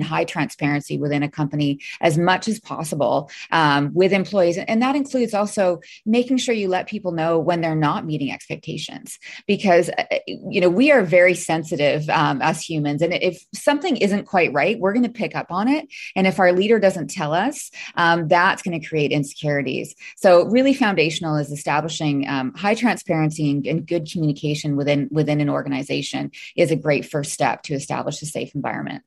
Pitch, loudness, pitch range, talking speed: 170 Hz, -20 LUFS, 150-200 Hz, 185 wpm